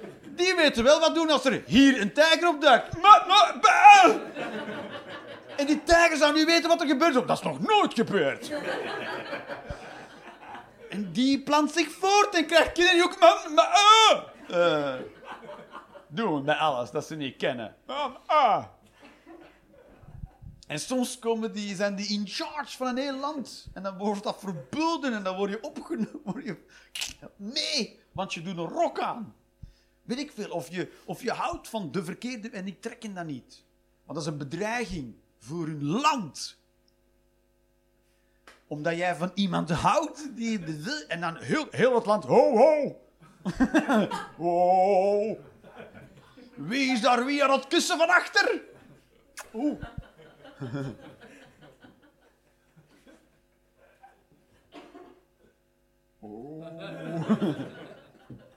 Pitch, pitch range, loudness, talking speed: 245 Hz, 185-305 Hz, -24 LUFS, 125 wpm